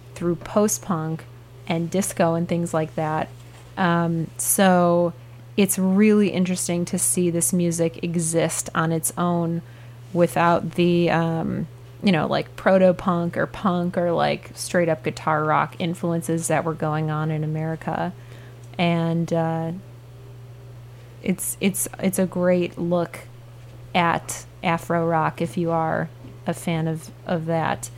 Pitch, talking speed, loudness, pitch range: 165 Hz, 130 wpm, -22 LUFS, 125-175 Hz